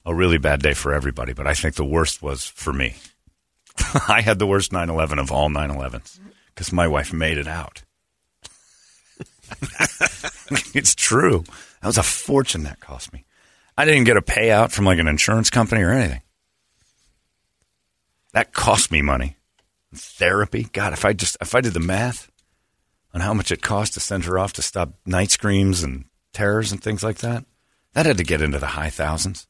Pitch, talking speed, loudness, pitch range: 85 Hz, 185 wpm, -20 LUFS, 75-105 Hz